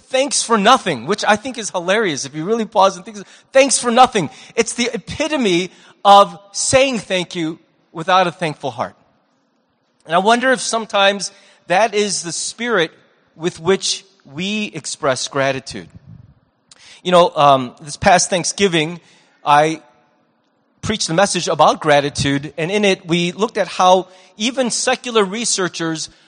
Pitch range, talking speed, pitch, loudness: 165-215 Hz, 145 wpm, 190 Hz, -16 LUFS